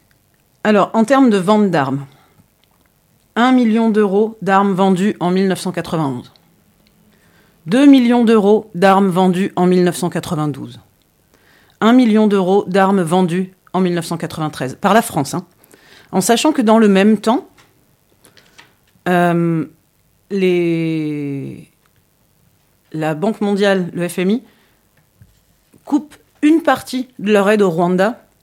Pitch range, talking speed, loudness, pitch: 170-215 Hz, 110 wpm, -15 LUFS, 190 Hz